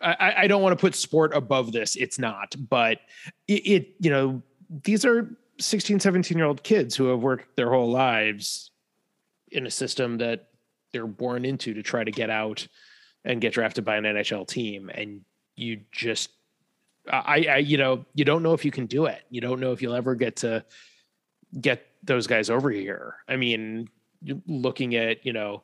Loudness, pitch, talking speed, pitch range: -25 LUFS, 130 Hz, 190 wpm, 115-155 Hz